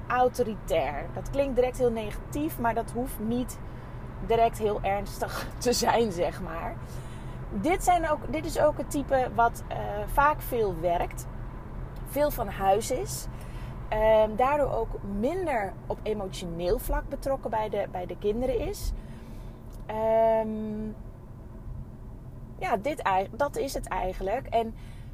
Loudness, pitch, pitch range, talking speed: -28 LUFS, 225 Hz, 185-255 Hz, 135 wpm